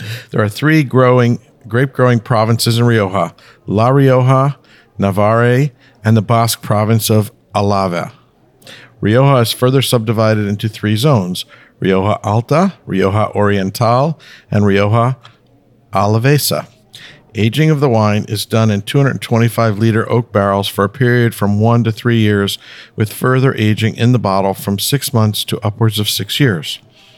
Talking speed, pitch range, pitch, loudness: 140 wpm, 105-125 Hz, 115 Hz, -14 LUFS